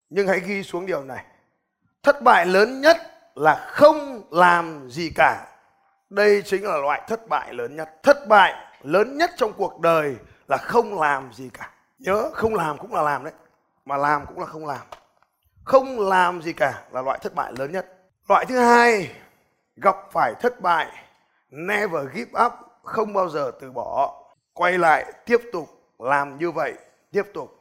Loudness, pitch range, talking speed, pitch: -21 LUFS, 165-245 Hz, 180 wpm, 195 Hz